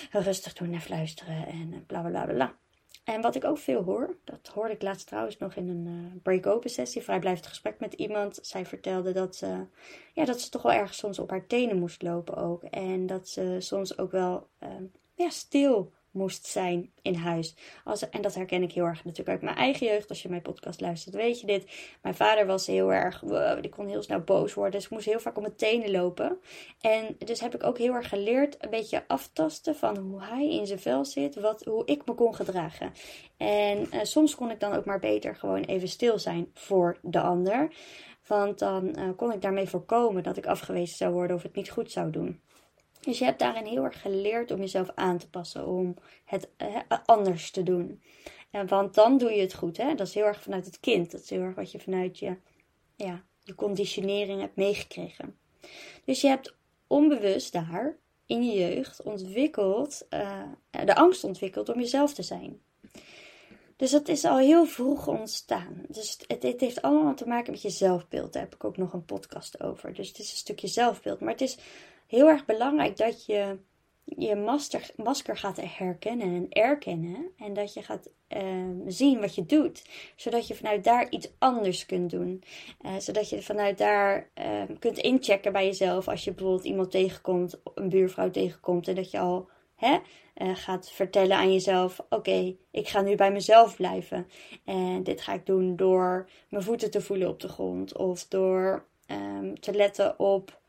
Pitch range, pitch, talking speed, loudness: 185-230 Hz, 195 Hz, 205 wpm, -28 LUFS